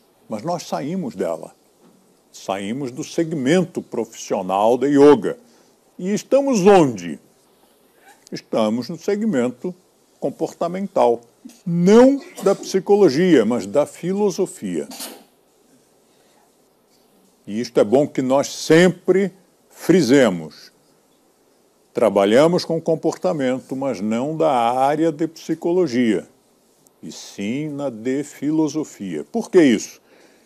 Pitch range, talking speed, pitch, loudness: 145-195 Hz, 95 wpm, 170 Hz, -19 LUFS